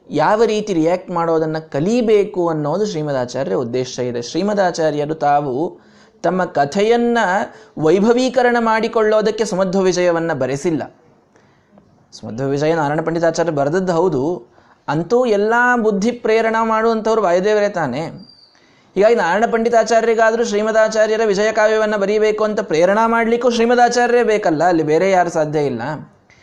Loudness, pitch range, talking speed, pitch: -16 LUFS, 160-225 Hz, 110 wpm, 205 Hz